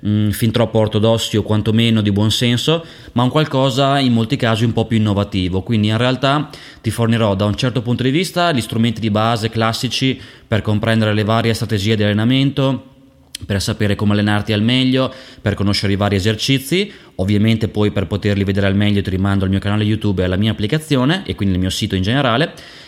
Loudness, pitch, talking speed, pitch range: -16 LUFS, 110 Hz, 195 wpm, 105-130 Hz